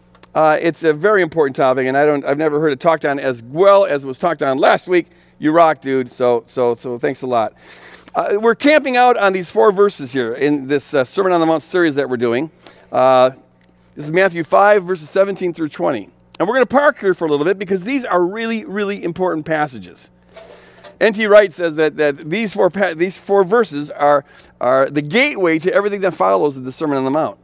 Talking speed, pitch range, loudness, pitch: 225 wpm, 135-195 Hz, -16 LUFS, 160 Hz